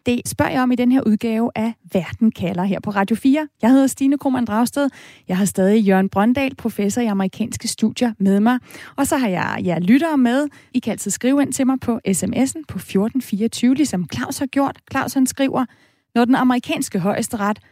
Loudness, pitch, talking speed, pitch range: -19 LUFS, 240 Hz, 205 wpm, 205-265 Hz